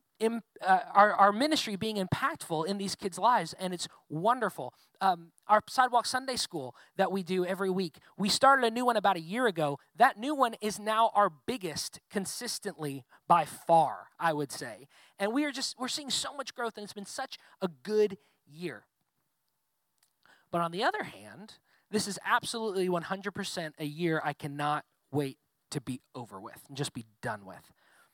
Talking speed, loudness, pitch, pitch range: 180 wpm, -30 LUFS, 195 Hz, 155-225 Hz